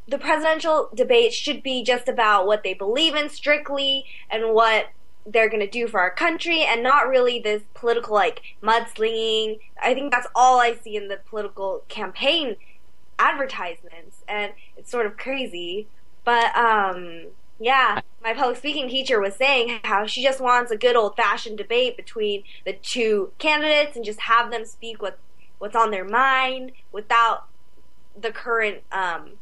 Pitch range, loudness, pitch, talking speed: 215-275 Hz, -21 LUFS, 235 Hz, 165 wpm